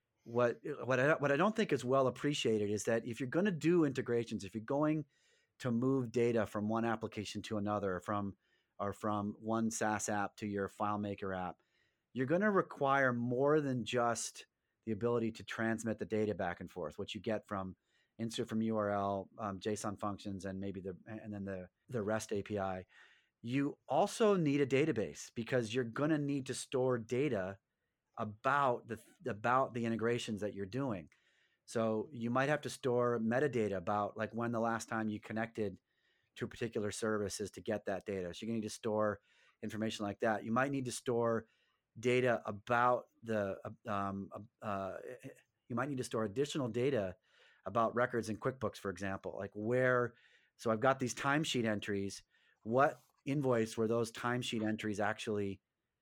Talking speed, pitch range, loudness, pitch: 180 wpm, 105-125 Hz, -37 LUFS, 115 Hz